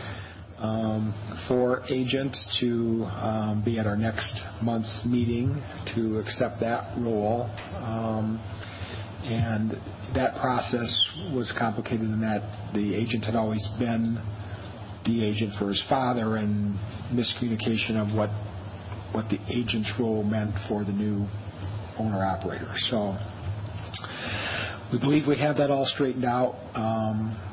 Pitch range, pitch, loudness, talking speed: 105-115 Hz, 110 Hz, -28 LUFS, 120 wpm